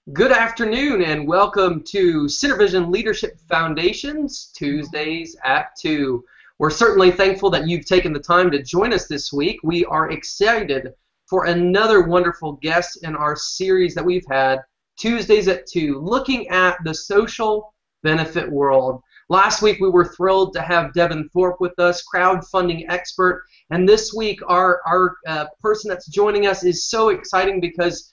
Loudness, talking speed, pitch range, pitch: -18 LUFS, 160 wpm, 160-200 Hz, 180 Hz